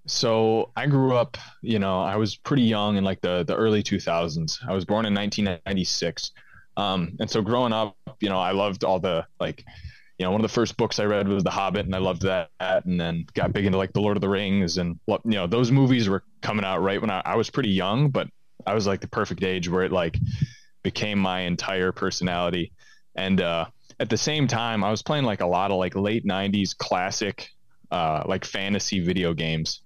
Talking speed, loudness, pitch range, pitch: 225 wpm, -25 LUFS, 95-110 Hz, 100 Hz